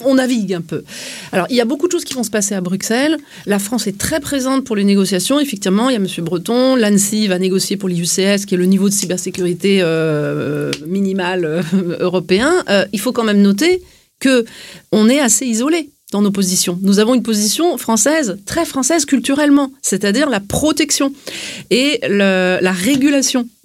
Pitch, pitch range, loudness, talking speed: 210 Hz, 185-265 Hz, -15 LUFS, 190 wpm